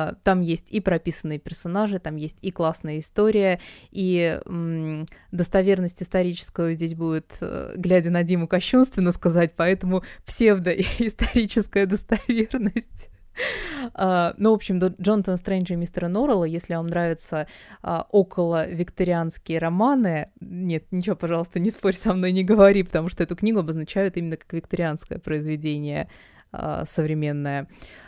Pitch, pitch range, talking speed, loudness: 180 Hz, 165-200 Hz, 130 wpm, -23 LUFS